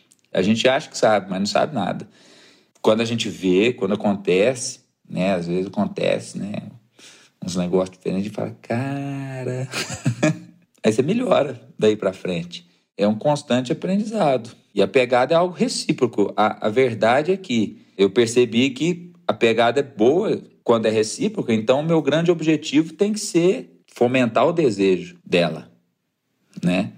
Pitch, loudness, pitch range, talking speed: 120 Hz, -21 LUFS, 100-155 Hz, 155 wpm